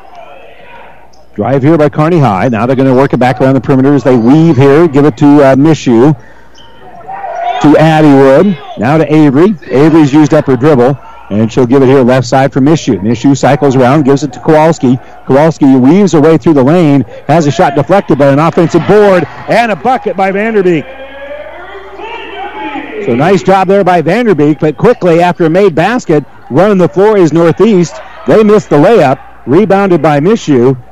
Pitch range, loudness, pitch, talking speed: 140-195 Hz, -7 LUFS, 155 Hz, 180 wpm